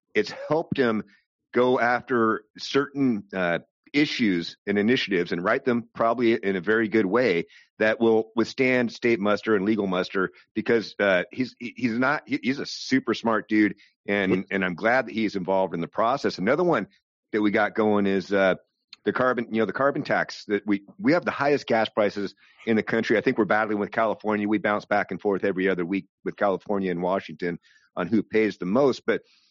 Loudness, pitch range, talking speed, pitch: -24 LUFS, 100-115 Hz, 195 wpm, 110 Hz